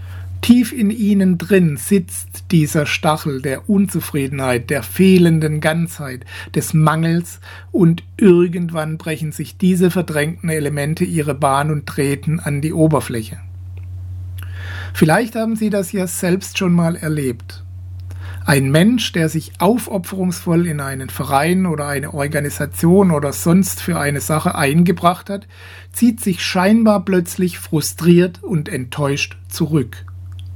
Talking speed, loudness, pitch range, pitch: 125 wpm, -17 LUFS, 130-180 Hz, 155 Hz